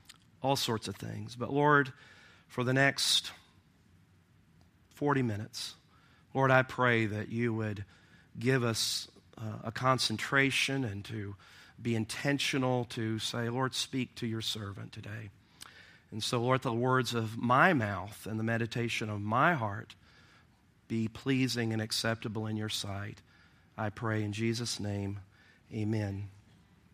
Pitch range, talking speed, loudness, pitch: 105-125 Hz, 135 wpm, -32 LUFS, 110 Hz